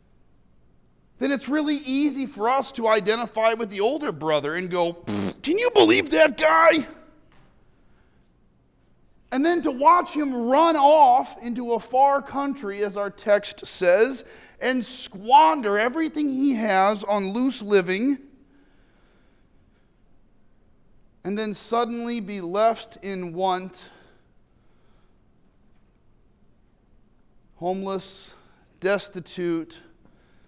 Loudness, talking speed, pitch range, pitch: -22 LUFS, 100 wpm, 185-275 Hz, 220 Hz